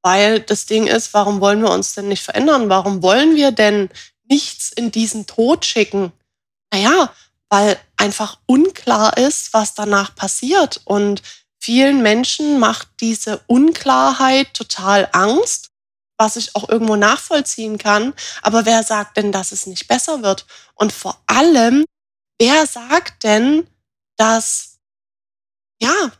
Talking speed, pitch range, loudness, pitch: 135 wpm, 200-265 Hz, -15 LUFS, 220 Hz